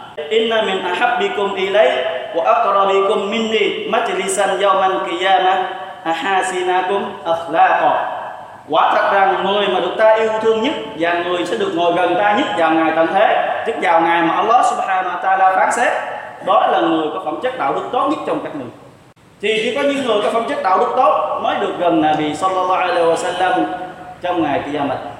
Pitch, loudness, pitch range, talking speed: 190 Hz, -16 LUFS, 180-215 Hz, 190 wpm